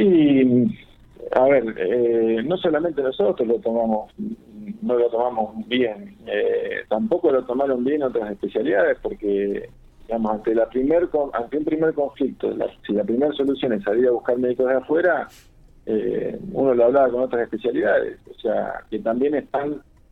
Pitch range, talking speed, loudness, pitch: 115-160 Hz, 160 wpm, -21 LUFS, 130 Hz